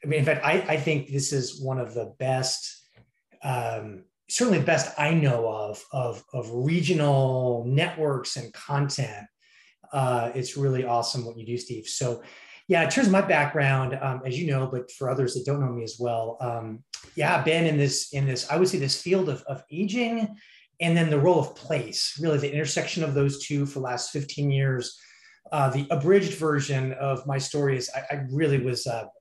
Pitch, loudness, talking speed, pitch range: 140 Hz, -26 LUFS, 200 wpm, 125-155 Hz